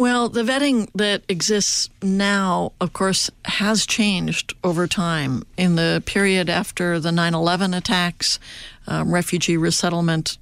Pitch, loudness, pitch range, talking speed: 180 Hz, -20 LUFS, 170-200 Hz, 135 wpm